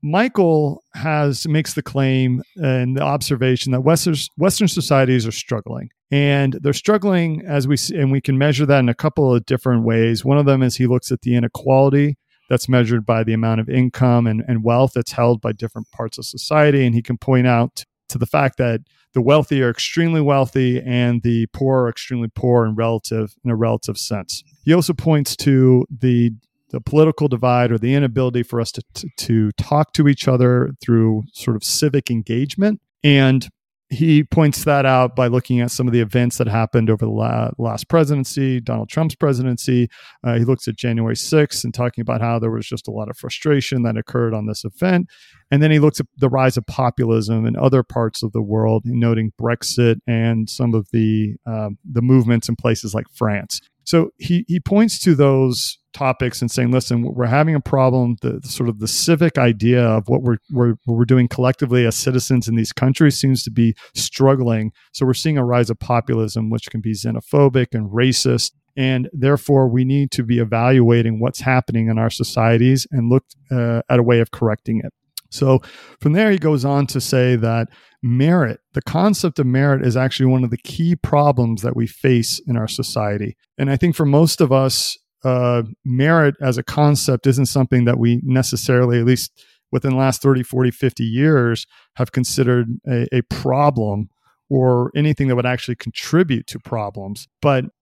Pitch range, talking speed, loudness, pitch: 115-140 Hz, 195 wpm, -17 LUFS, 125 Hz